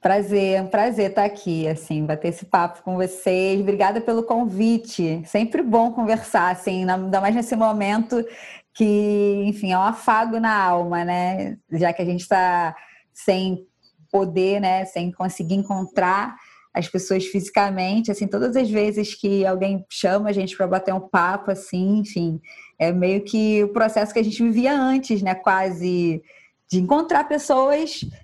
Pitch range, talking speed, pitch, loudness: 185-215 Hz, 160 wpm, 195 Hz, -21 LUFS